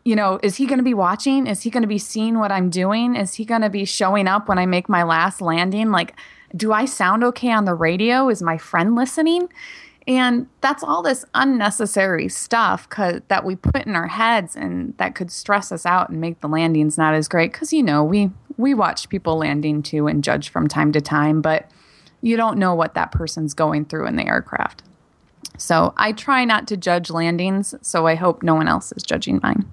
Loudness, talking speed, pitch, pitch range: -19 LUFS, 220 wpm, 195 Hz, 165-230 Hz